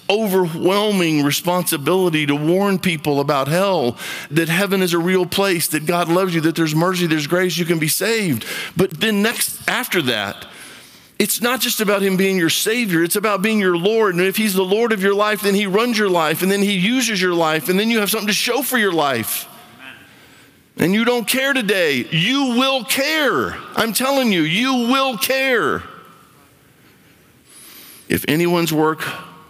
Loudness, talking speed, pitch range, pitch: -17 LUFS, 185 wpm, 170-220 Hz, 190 Hz